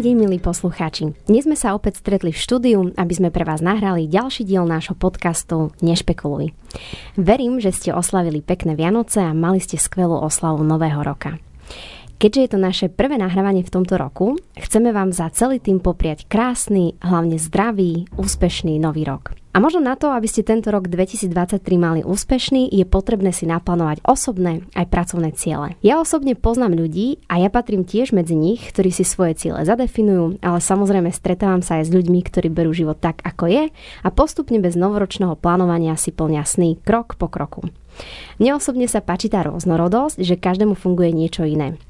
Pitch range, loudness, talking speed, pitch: 165-210 Hz, -18 LUFS, 175 wpm, 185 Hz